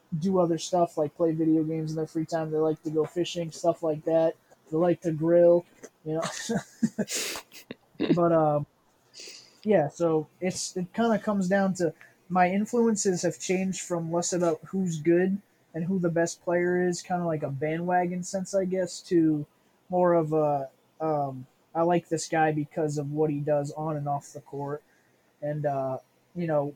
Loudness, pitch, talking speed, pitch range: -27 LUFS, 165 Hz, 185 wpm, 155-180 Hz